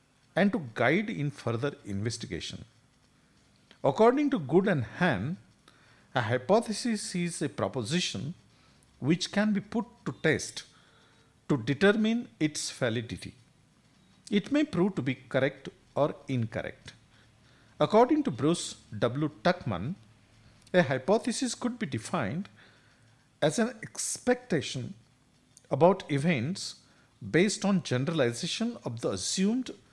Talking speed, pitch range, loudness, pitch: 110 wpm, 125-205 Hz, -29 LUFS, 150 Hz